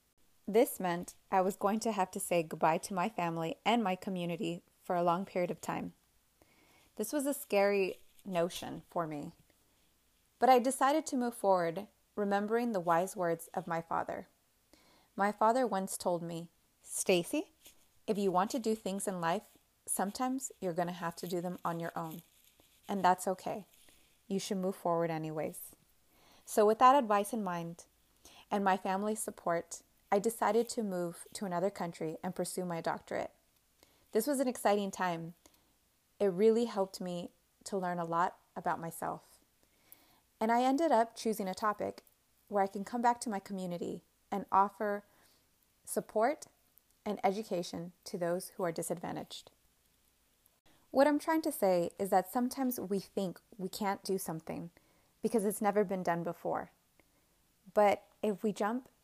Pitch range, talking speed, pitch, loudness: 175-220 Hz, 165 wpm, 195 Hz, -34 LUFS